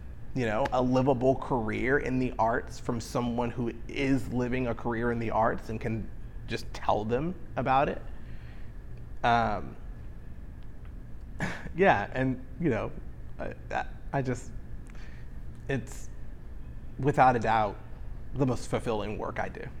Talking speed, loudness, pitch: 130 wpm, -30 LUFS, 115 Hz